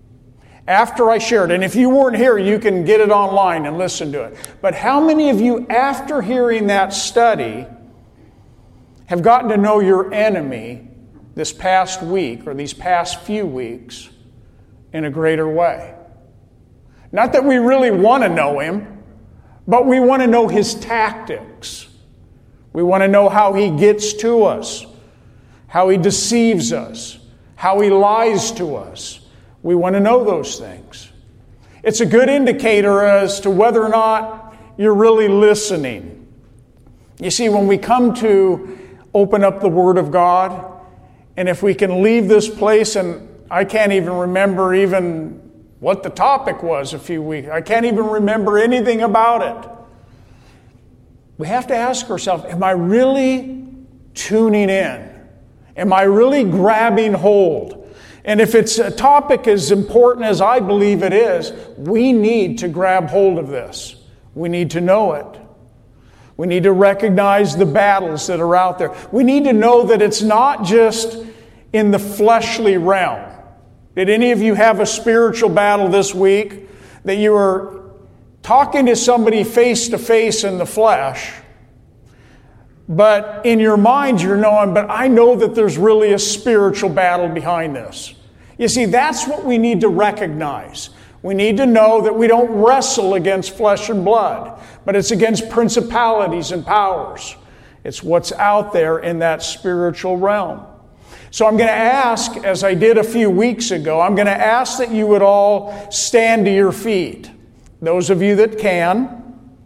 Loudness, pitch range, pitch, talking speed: -14 LUFS, 175-225 Hz, 200 Hz, 160 wpm